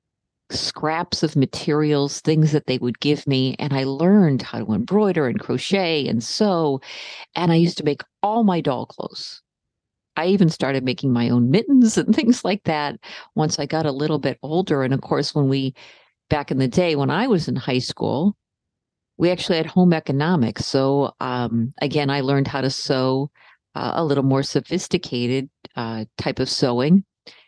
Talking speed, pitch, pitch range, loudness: 180 wpm, 145 Hz, 130-170 Hz, -21 LUFS